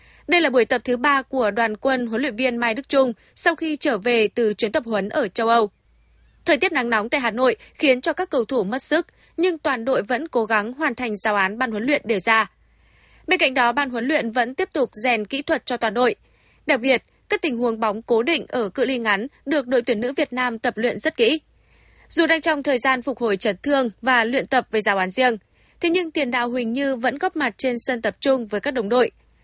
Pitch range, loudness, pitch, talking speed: 230-290 Hz, -21 LUFS, 255 Hz, 255 wpm